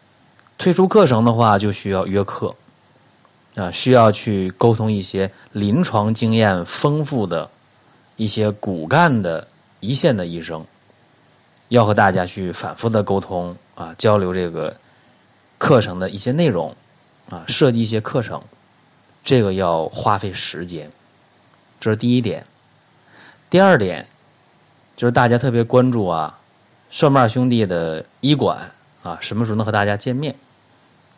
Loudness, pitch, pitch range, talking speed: -18 LUFS, 110 Hz, 100-125 Hz, 205 characters per minute